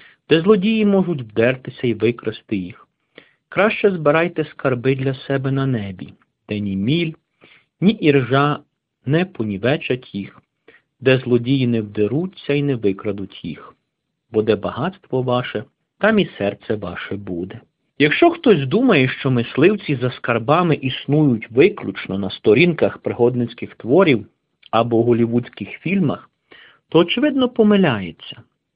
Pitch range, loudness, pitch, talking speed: 115-165 Hz, -18 LUFS, 130 Hz, 120 wpm